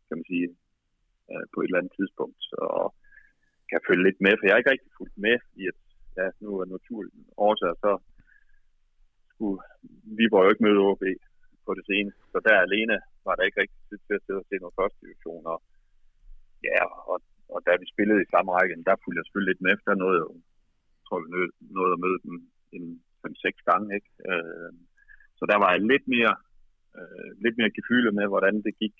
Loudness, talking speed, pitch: -25 LUFS, 215 wpm, 105 Hz